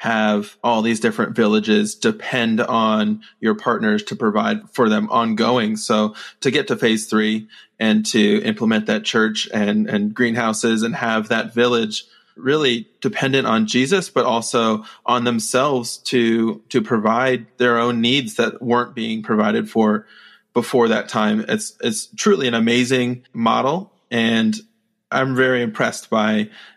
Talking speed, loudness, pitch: 145 wpm, -19 LUFS, 120 Hz